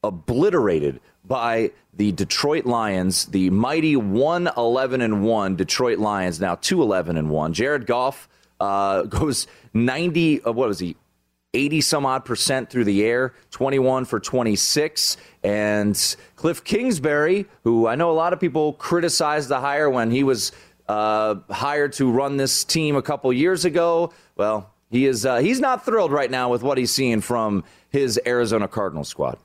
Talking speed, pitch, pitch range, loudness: 165 wpm, 125 Hz, 105-150 Hz, -21 LUFS